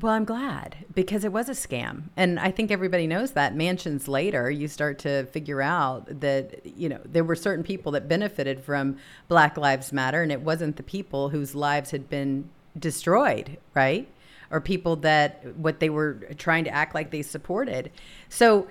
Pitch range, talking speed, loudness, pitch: 145-180 Hz, 185 wpm, -26 LUFS, 155 Hz